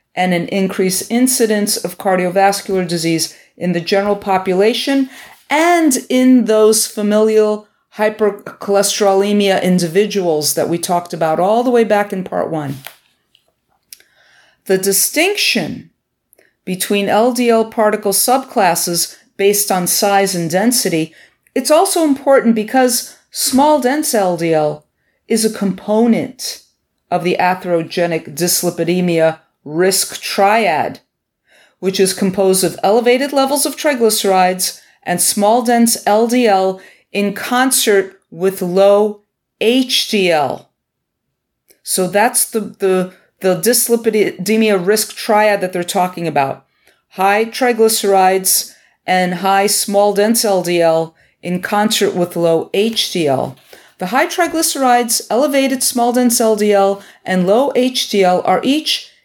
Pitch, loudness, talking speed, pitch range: 205 Hz, -14 LUFS, 110 wpm, 185-235 Hz